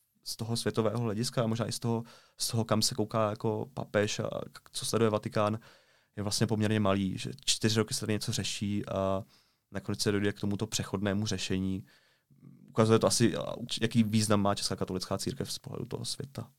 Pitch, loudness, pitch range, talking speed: 110 Hz, -31 LUFS, 100-115 Hz, 190 wpm